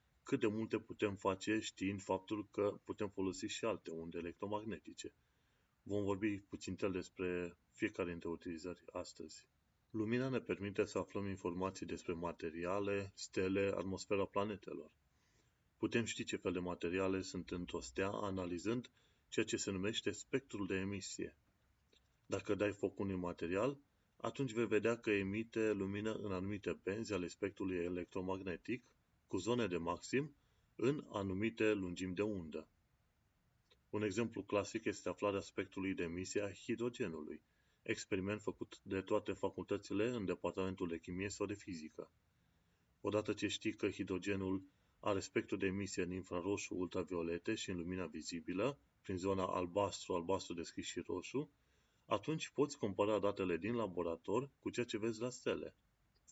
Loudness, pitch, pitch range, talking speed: -42 LUFS, 100 Hz, 90-105 Hz, 145 wpm